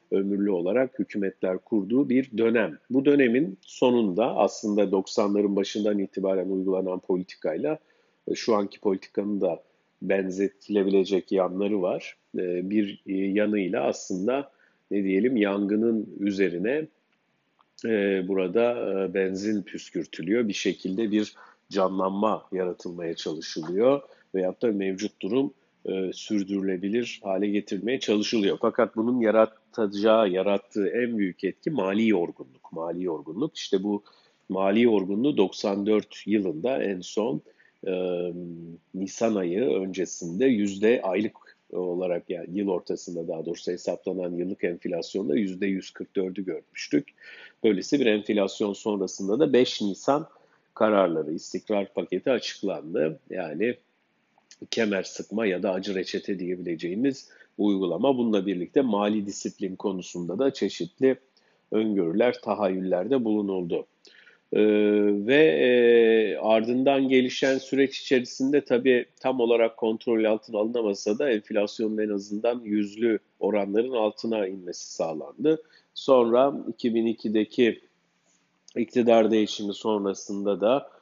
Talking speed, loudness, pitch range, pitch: 105 wpm, -26 LUFS, 95-115 Hz, 105 Hz